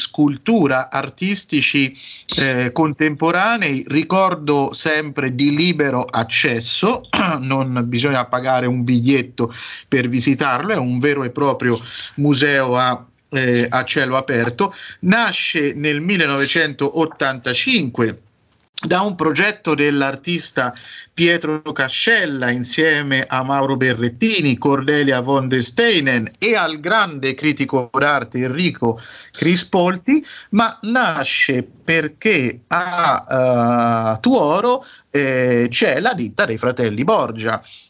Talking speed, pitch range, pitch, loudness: 100 wpm, 125-160 Hz, 140 Hz, -16 LUFS